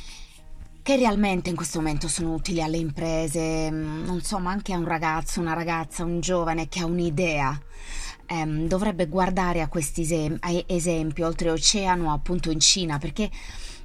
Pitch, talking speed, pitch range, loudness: 165 Hz, 160 wpm, 155-180 Hz, -25 LUFS